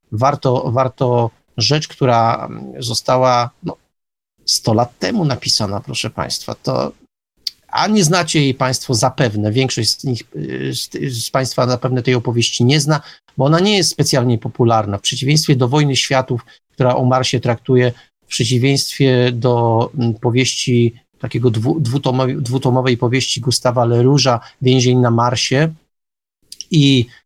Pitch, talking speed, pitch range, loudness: 130 Hz, 130 wpm, 120-135 Hz, -16 LUFS